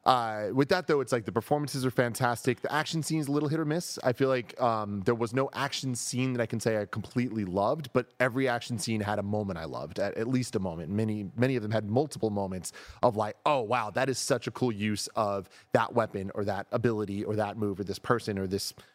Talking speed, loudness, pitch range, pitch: 245 wpm, -30 LUFS, 105-130 Hz, 120 Hz